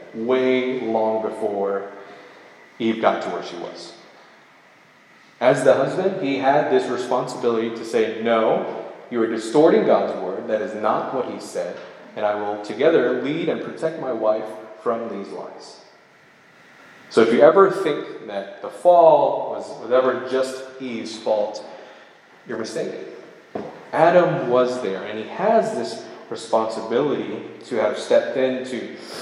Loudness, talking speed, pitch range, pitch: -21 LUFS, 145 wpm, 110-135 Hz, 125 Hz